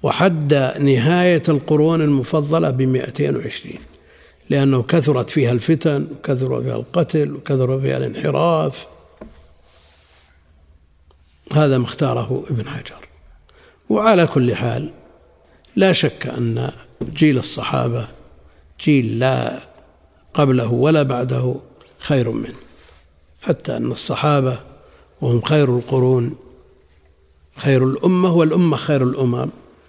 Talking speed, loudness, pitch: 95 wpm, -18 LUFS, 130 Hz